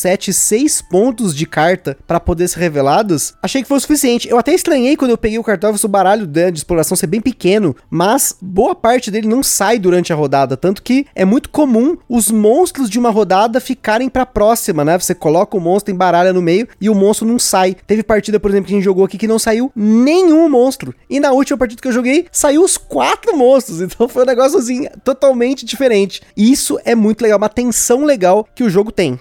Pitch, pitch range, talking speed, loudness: 220 Hz, 190-260 Hz, 225 wpm, -13 LUFS